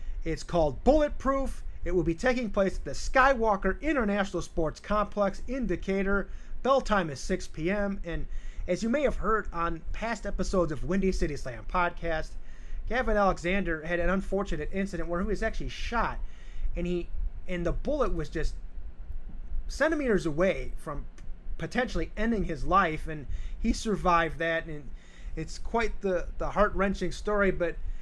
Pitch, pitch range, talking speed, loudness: 180 Hz, 165-205 Hz, 155 wpm, -30 LUFS